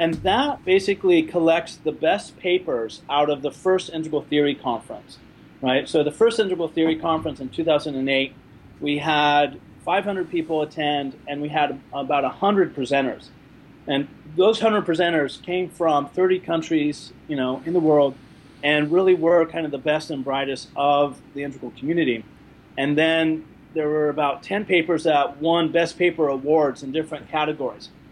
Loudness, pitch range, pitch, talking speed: -22 LUFS, 145-170 Hz, 155 Hz, 160 wpm